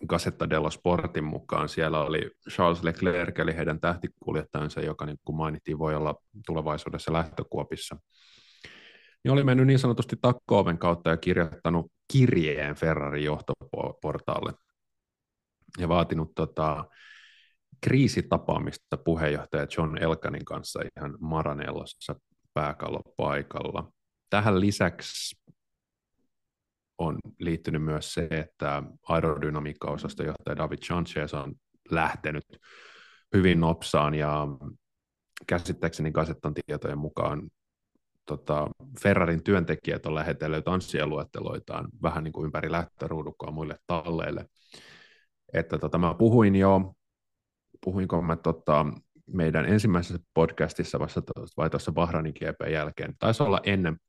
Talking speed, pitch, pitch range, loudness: 105 wpm, 80 Hz, 75-90 Hz, -28 LUFS